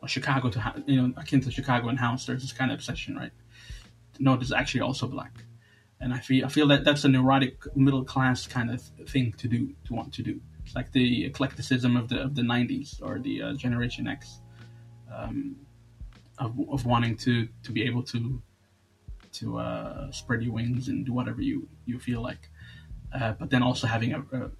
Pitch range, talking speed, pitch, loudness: 115-130 Hz, 200 wpm, 125 Hz, -28 LUFS